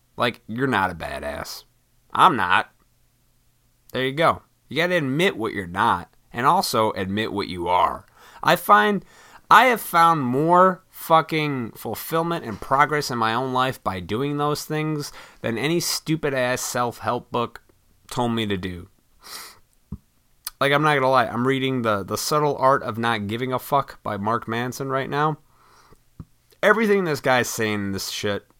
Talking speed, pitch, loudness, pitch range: 165 wpm, 130 Hz, -22 LUFS, 110-150 Hz